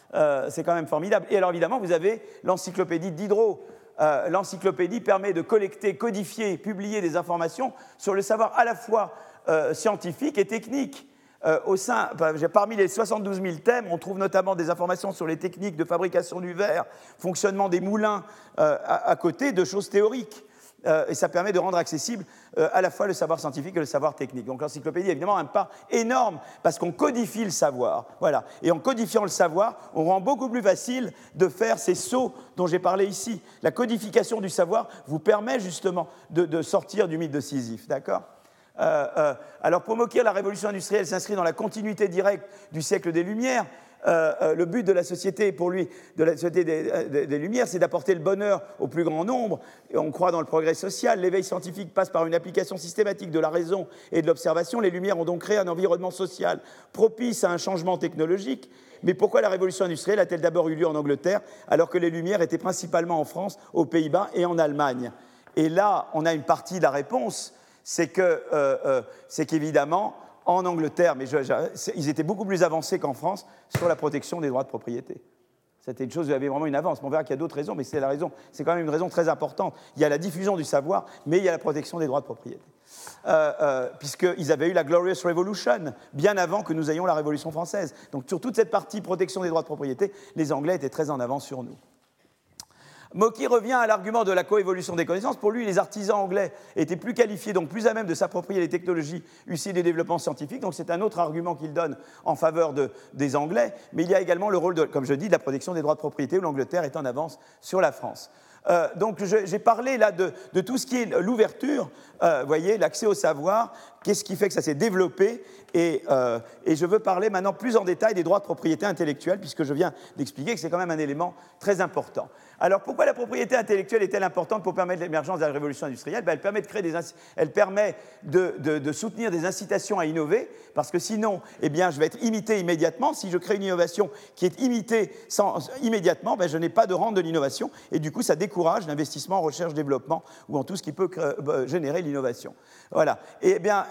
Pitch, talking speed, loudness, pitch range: 180 Hz, 225 wpm, -25 LUFS, 160-205 Hz